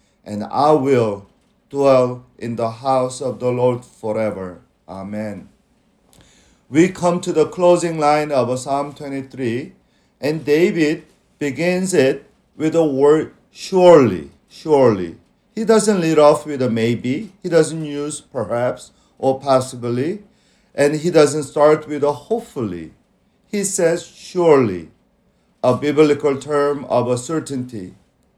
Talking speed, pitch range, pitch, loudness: 125 wpm, 125-160 Hz, 145 Hz, -18 LUFS